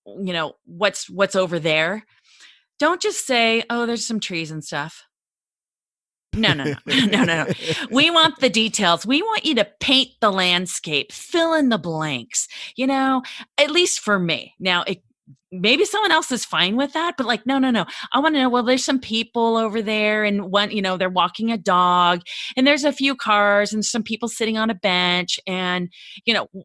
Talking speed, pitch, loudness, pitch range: 205 wpm, 220 Hz, -19 LUFS, 185-260 Hz